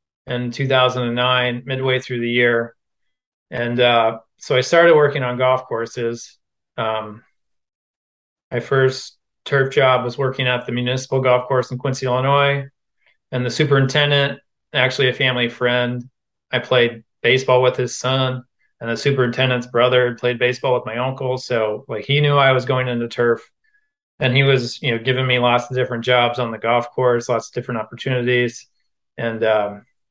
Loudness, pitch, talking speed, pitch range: -18 LUFS, 125 Hz, 165 wpm, 120-130 Hz